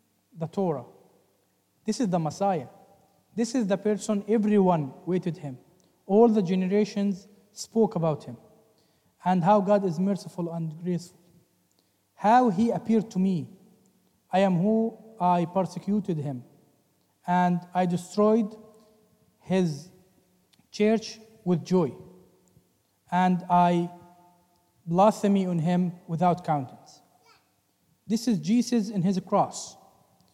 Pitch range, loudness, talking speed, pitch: 175-210 Hz, -26 LUFS, 115 wpm, 185 Hz